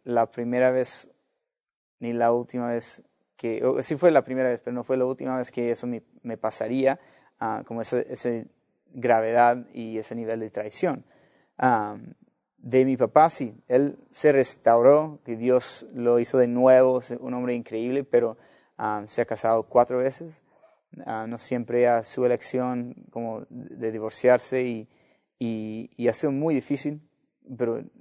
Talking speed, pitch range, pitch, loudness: 165 wpm, 115-130 Hz, 125 Hz, -24 LUFS